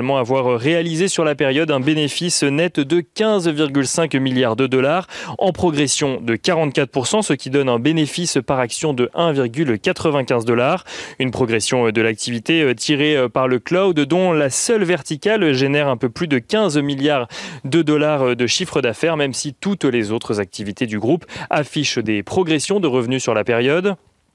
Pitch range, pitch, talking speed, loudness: 130-165 Hz, 145 Hz, 165 wpm, -18 LUFS